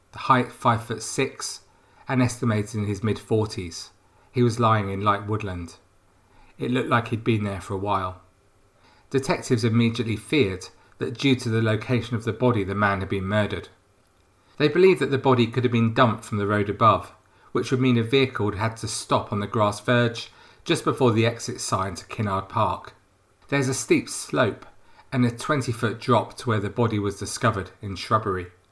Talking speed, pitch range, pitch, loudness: 195 wpm, 100-120 Hz, 110 Hz, -24 LUFS